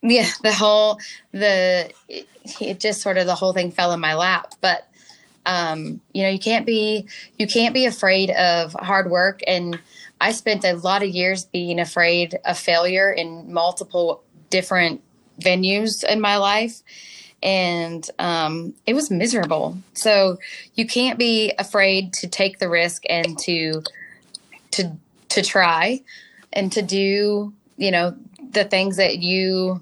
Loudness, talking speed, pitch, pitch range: -20 LUFS, 155 wpm, 190 Hz, 175-210 Hz